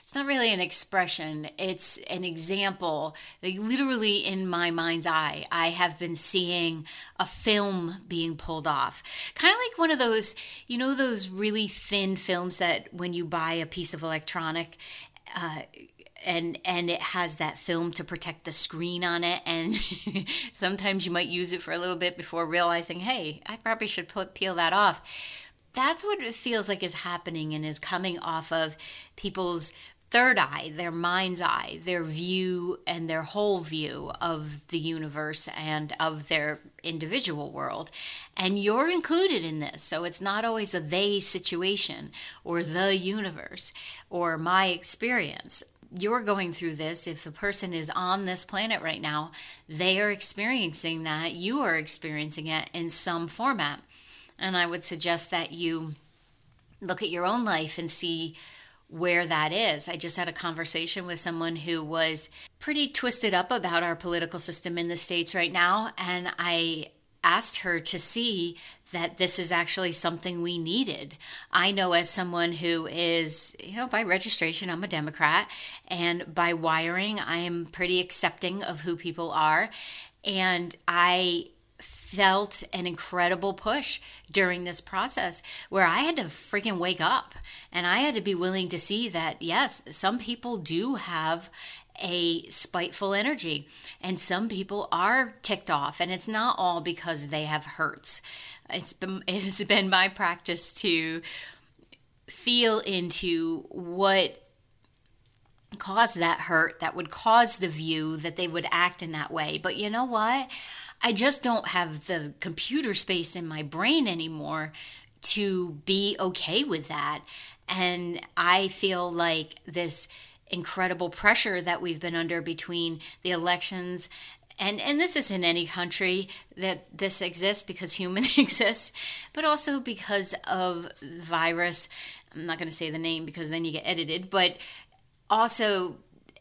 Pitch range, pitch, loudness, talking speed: 165-195 Hz, 175 Hz, -25 LUFS, 160 wpm